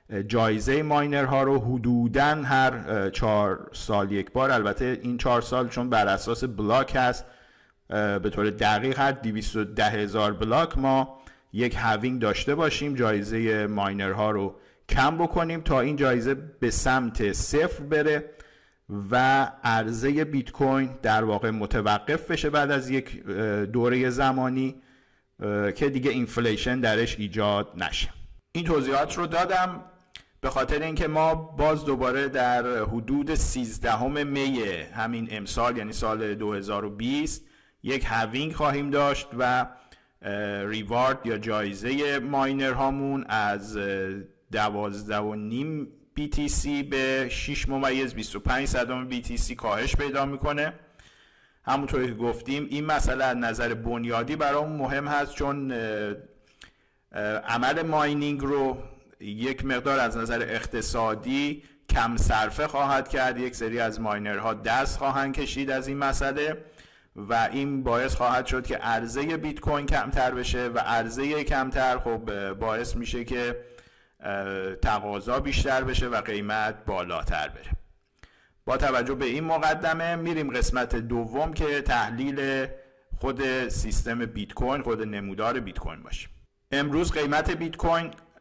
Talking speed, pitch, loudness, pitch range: 125 wpm, 125 Hz, -26 LUFS, 110-140 Hz